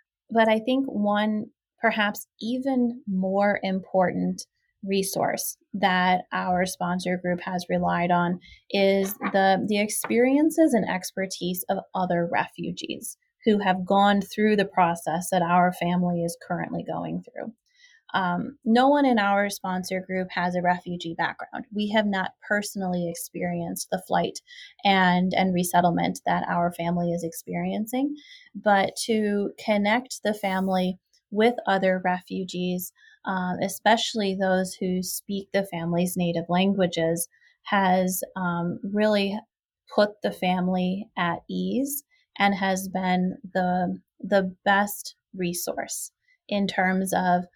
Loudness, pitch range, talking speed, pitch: -25 LUFS, 180-210 Hz, 125 wpm, 190 Hz